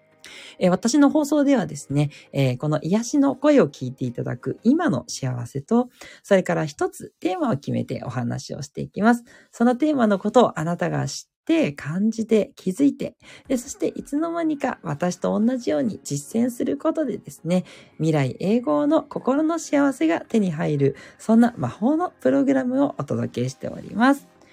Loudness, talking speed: -22 LUFS, 330 characters per minute